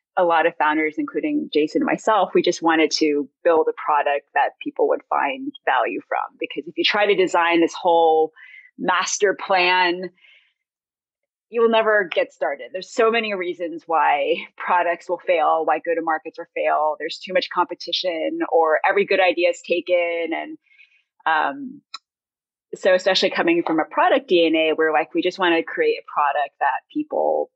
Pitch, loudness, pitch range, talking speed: 180 Hz, -20 LUFS, 165-255 Hz, 175 wpm